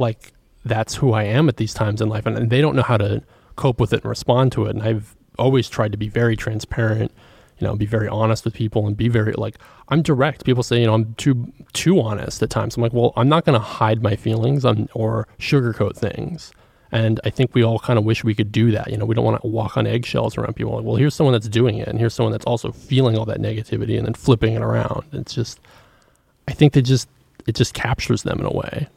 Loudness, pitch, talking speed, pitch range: -20 LUFS, 115 Hz, 260 wpm, 110-125 Hz